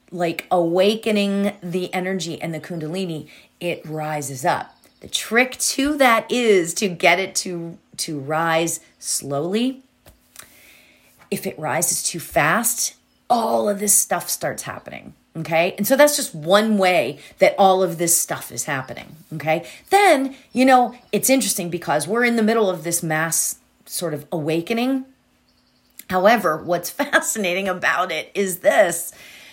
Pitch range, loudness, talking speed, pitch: 165-220 Hz, -20 LUFS, 145 wpm, 185 Hz